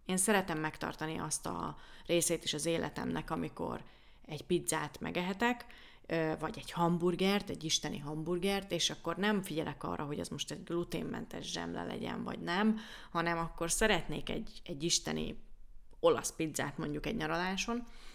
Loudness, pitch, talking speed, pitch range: -35 LUFS, 170 Hz, 145 wpm, 155-195 Hz